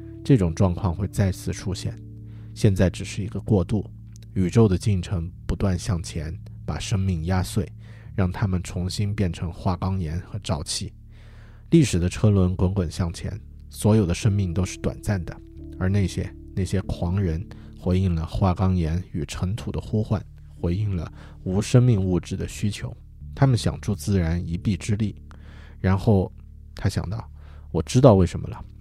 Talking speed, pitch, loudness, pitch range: 240 characters per minute, 95 Hz, -24 LUFS, 85-105 Hz